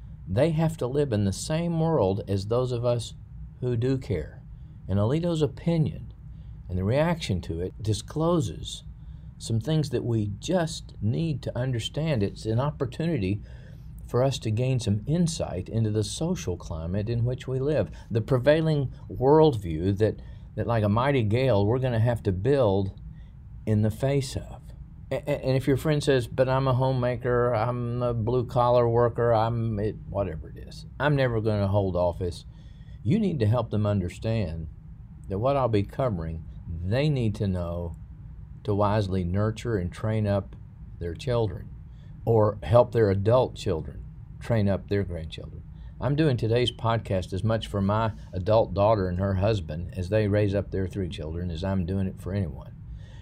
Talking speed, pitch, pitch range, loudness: 170 wpm, 110 Hz, 100-130 Hz, -26 LUFS